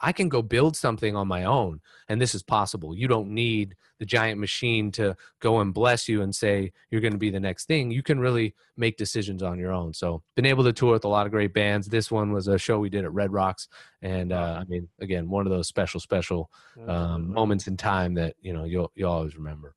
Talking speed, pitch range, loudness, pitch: 250 wpm, 90-115 Hz, -26 LUFS, 100 Hz